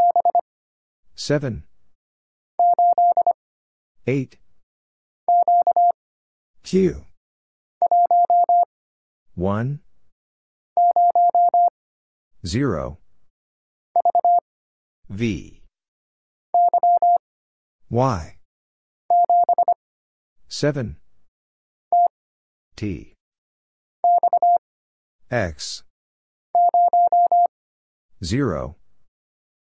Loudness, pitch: -19 LUFS, 350 Hz